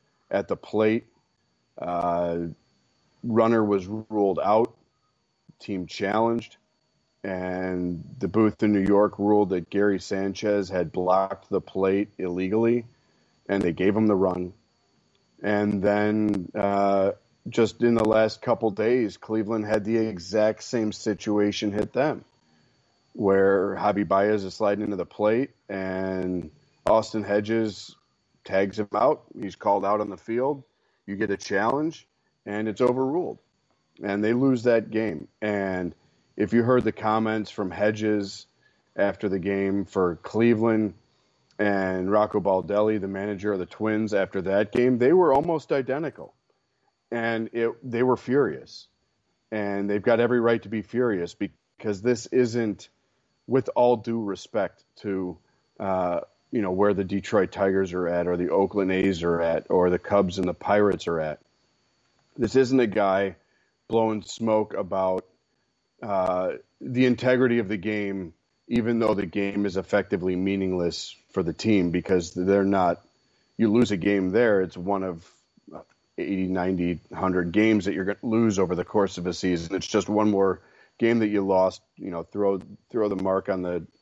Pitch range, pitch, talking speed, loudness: 95-110 Hz, 100 Hz, 155 wpm, -25 LUFS